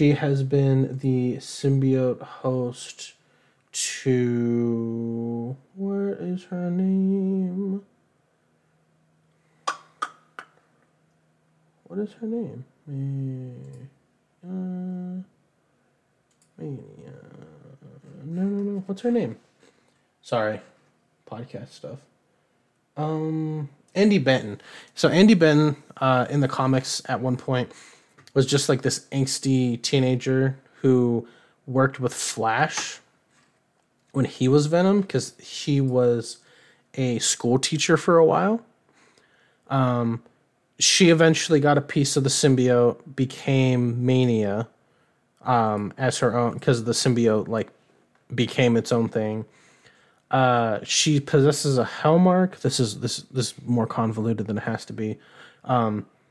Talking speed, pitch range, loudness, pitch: 110 wpm, 120-155 Hz, -23 LUFS, 135 Hz